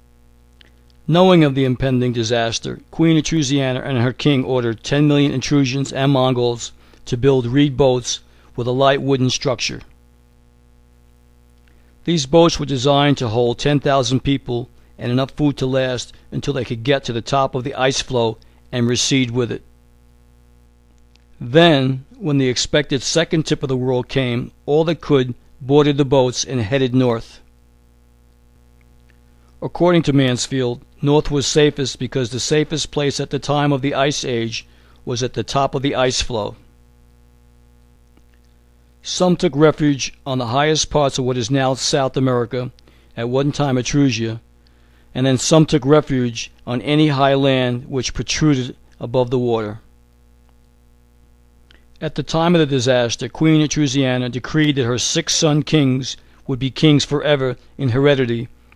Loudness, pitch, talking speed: -17 LUFS, 130 Hz, 150 wpm